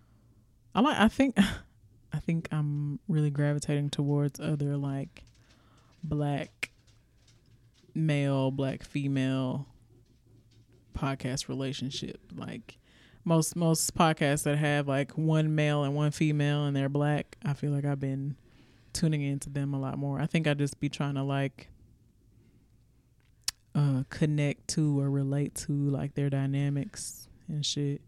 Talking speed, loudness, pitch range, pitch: 135 wpm, -30 LUFS, 125-145 Hz, 140 Hz